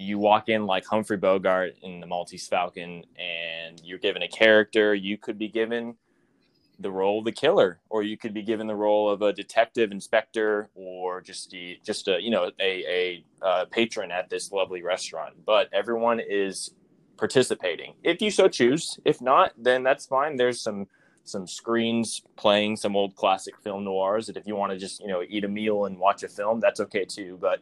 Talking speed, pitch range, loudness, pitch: 200 wpm, 95-115 Hz, -25 LUFS, 105 Hz